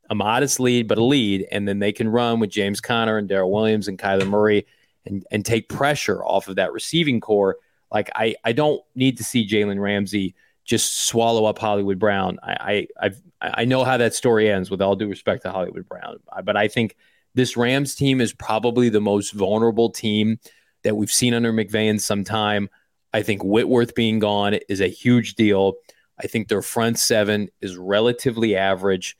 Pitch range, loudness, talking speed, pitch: 100-115 Hz, -21 LUFS, 195 wpm, 110 Hz